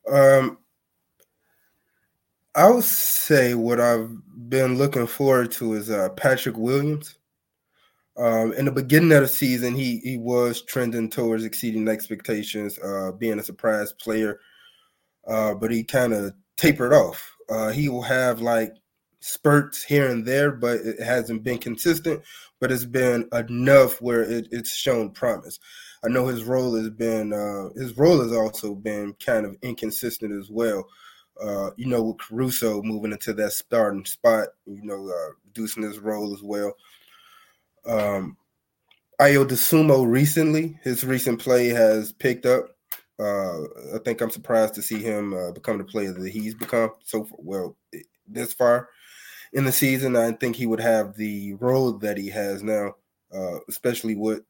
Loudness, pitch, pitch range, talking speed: -23 LUFS, 115 Hz, 110-130 Hz, 160 wpm